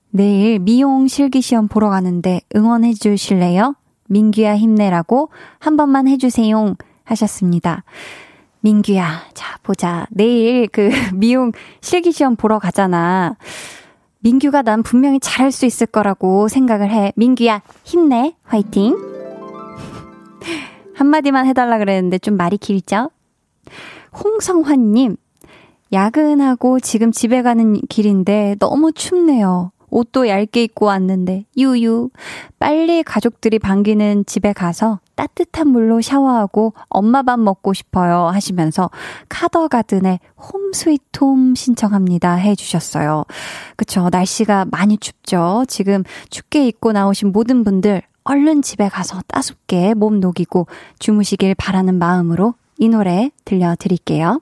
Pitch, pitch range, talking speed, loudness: 215 Hz, 195-255 Hz, 270 characters per minute, -15 LUFS